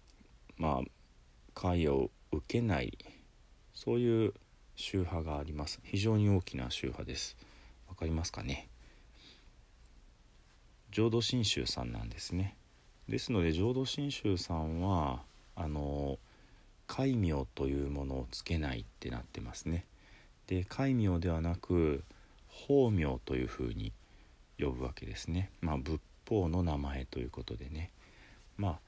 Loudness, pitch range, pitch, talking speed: -36 LUFS, 70-100 Hz, 85 Hz, 245 characters per minute